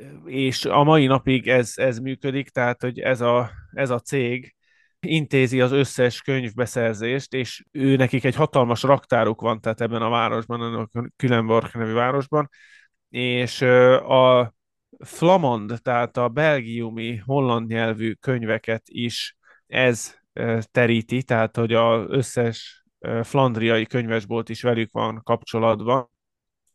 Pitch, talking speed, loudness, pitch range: 120 Hz, 125 wpm, -21 LUFS, 115-130 Hz